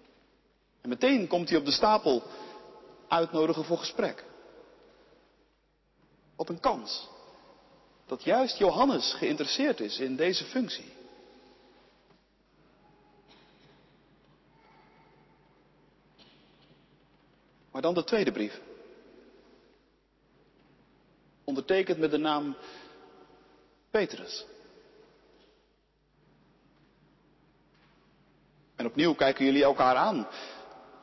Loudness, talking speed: -28 LUFS, 70 wpm